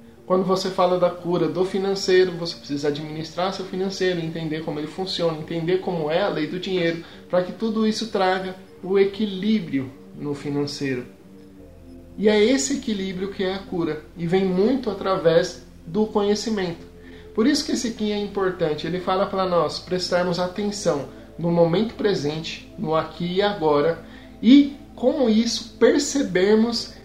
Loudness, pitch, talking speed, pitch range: -22 LUFS, 185 Hz, 155 wpm, 160-205 Hz